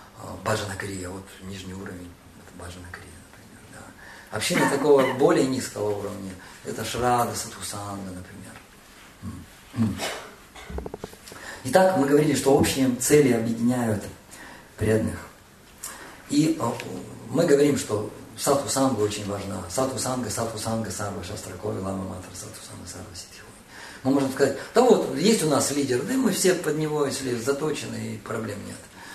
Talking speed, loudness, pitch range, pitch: 130 wpm, -24 LUFS, 95-135 Hz, 110 Hz